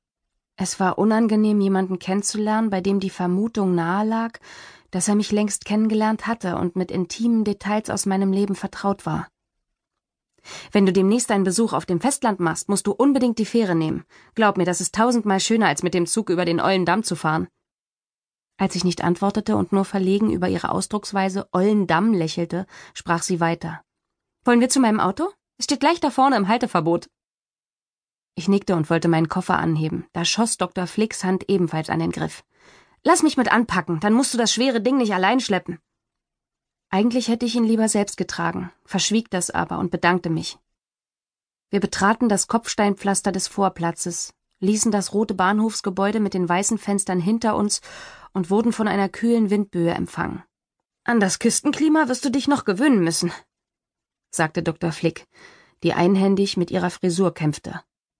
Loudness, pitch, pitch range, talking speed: -21 LUFS, 200 Hz, 180-220 Hz, 170 wpm